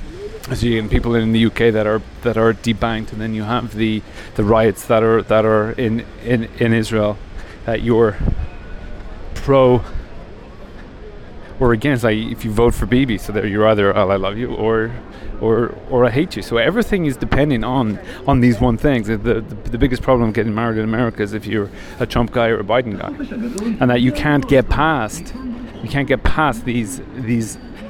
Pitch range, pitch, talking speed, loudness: 110-125 Hz, 115 Hz, 200 wpm, -17 LUFS